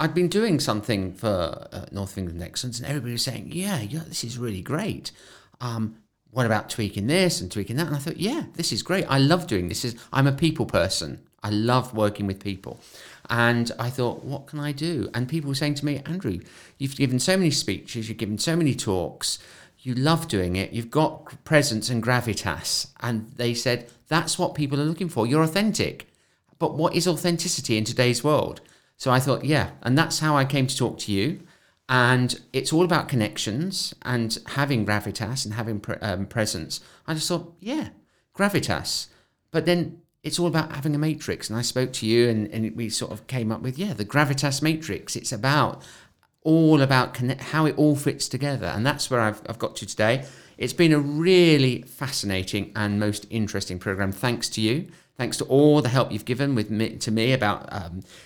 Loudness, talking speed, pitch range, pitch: -24 LUFS, 205 wpm, 110-150 Hz, 125 Hz